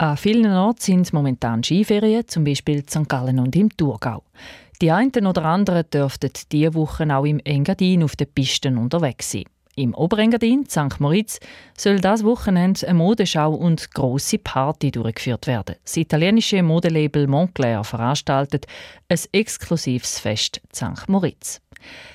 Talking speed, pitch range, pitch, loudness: 140 wpm, 135-190 Hz, 155 Hz, -20 LUFS